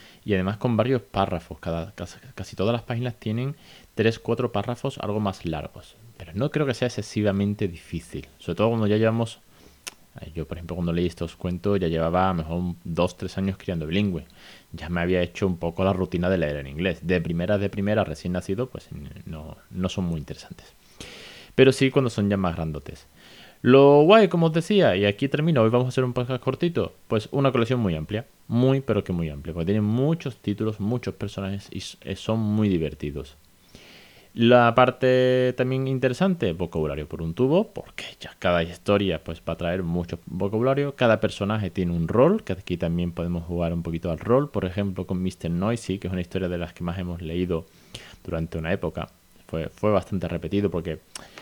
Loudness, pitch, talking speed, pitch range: -24 LUFS, 95 Hz, 195 wpm, 85-115 Hz